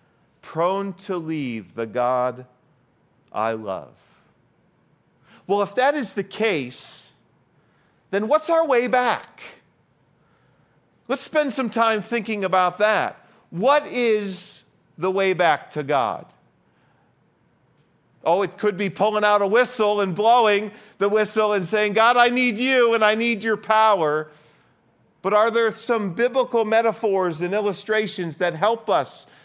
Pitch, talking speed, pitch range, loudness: 210 Hz, 135 wpm, 175-230 Hz, -21 LUFS